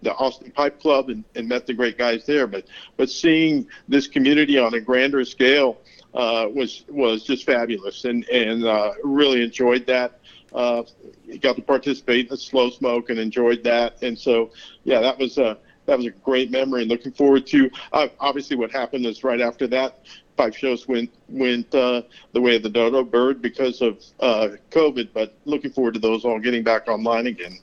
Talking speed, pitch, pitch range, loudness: 195 wpm, 125 Hz, 120-135 Hz, -21 LUFS